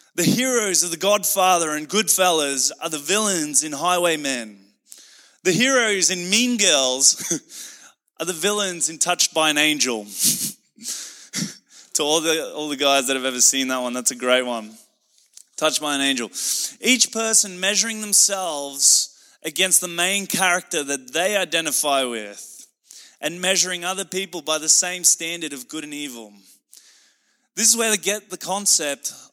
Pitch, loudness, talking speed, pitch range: 170 Hz, -19 LUFS, 155 wpm, 140-195 Hz